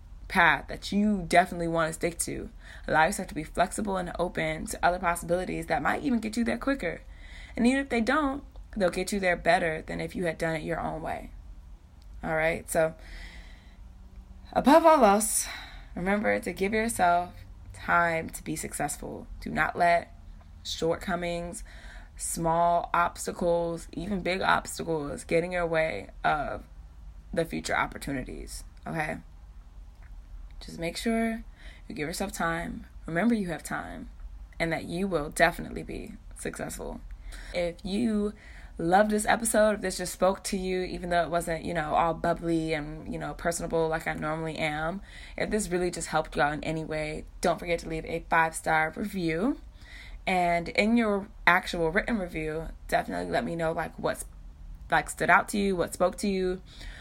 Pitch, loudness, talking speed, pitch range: 170 Hz, -28 LUFS, 165 wpm, 155-195 Hz